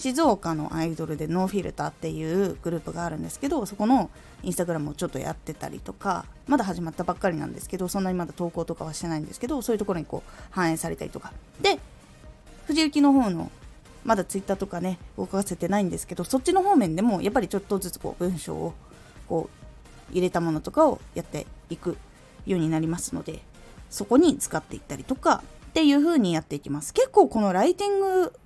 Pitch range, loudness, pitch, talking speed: 170-265 Hz, -26 LUFS, 190 Hz, 455 characters per minute